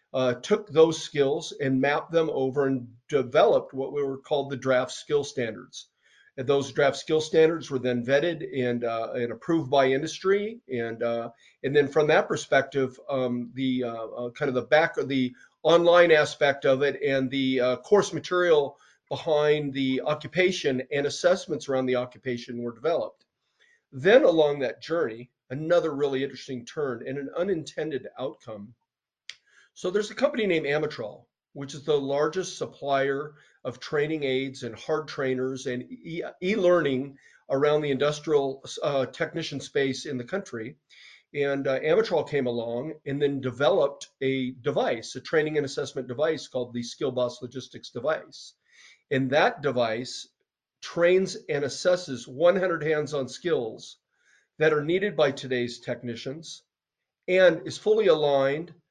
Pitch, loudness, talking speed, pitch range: 140 Hz, -26 LUFS, 150 wpm, 130-155 Hz